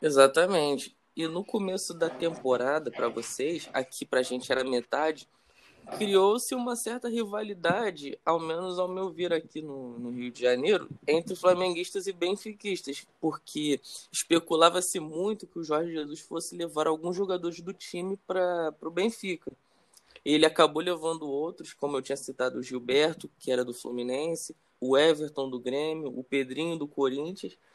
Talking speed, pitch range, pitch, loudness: 155 wpm, 140-185 Hz, 165 Hz, -29 LUFS